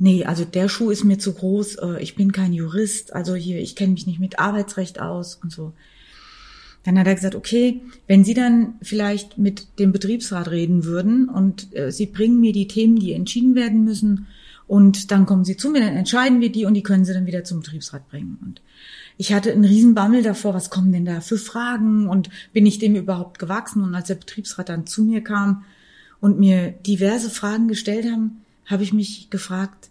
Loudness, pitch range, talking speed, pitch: -19 LUFS, 185-220 Hz, 205 wpm, 200 Hz